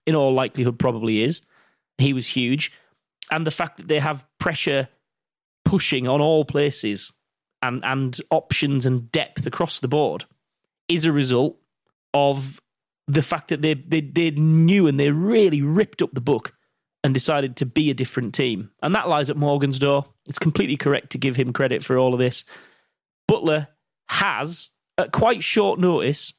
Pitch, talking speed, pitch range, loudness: 145 Hz, 170 wpm, 130-155 Hz, -21 LUFS